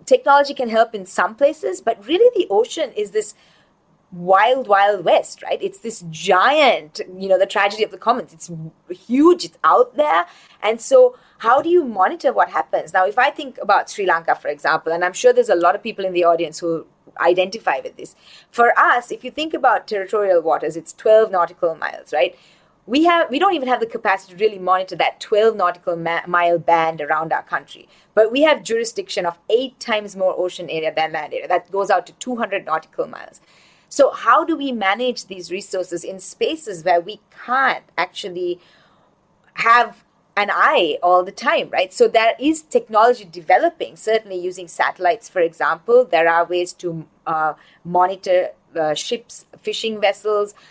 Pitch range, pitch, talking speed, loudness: 175-255 Hz, 205 Hz, 185 wpm, -18 LUFS